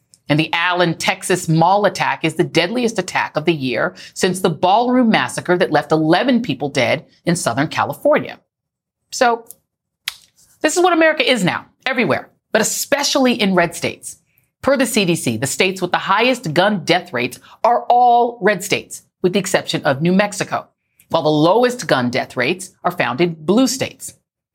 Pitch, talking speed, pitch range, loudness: 180 Hz, 170 wpm, 160-225 Hz, -17 LUFS